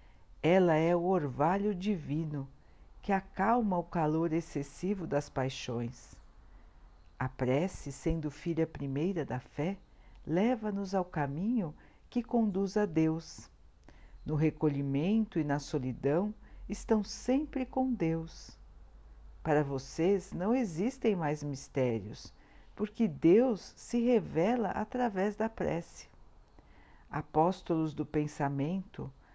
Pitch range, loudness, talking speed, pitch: 140-200 Hz, -33 LUFS, 105 wpm, 160 Hz